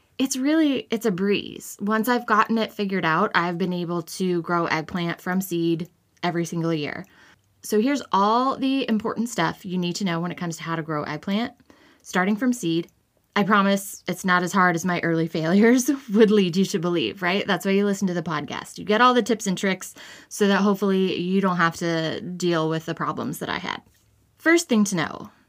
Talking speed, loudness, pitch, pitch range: 215 wpm, -23 LUFS, 190 Hz, 170-220 Hz